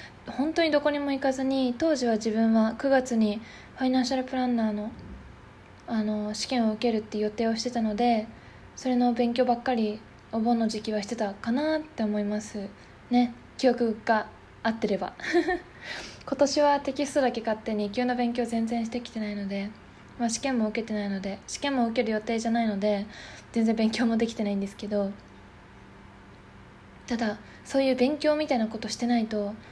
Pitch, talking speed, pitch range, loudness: 230 Hz, 350 characters per minute, 215-255 Hz, -27 LUFS